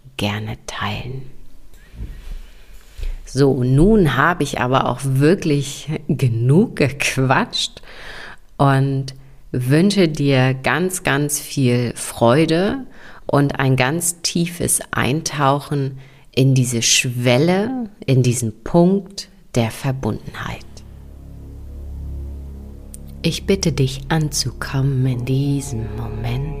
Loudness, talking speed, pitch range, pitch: -18 LUFS, 85 wpm, 115-150 Hz, 135 Hz